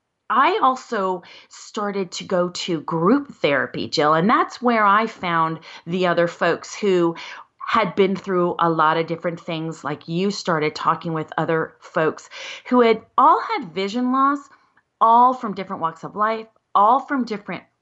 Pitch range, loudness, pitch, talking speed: 170-230 Hz, -20 LUFS, 190 Hz, 160 wpm